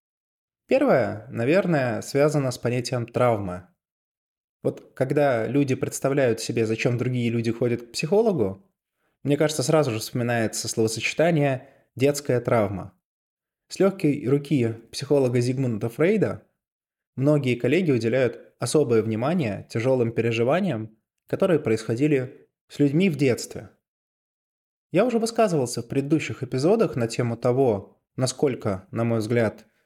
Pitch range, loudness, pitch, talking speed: 115-145 Hz, -24 LUFS, 125 Hz, 115 wpm